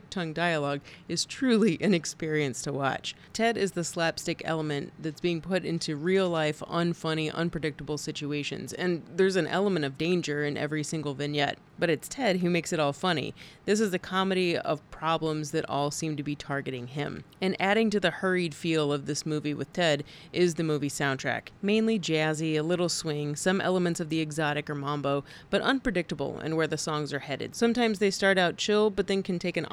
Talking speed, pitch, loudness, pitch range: 200 wpm, 160 Hz, -29 LUFS, 150-185 Hz